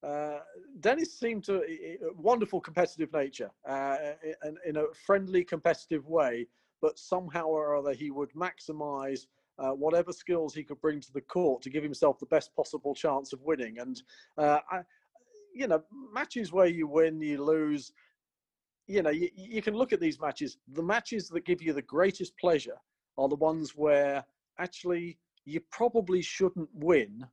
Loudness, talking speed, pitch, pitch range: -31 LUFS, 170 wpm, 160 Hz, 145-190 Hz